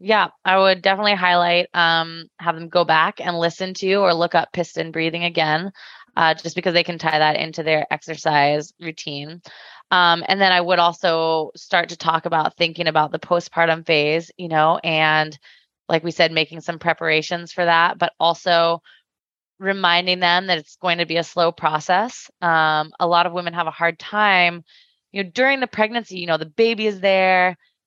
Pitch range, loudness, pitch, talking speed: 160-180 Hz, -19 LUFS, 170 Hz, 190 wpm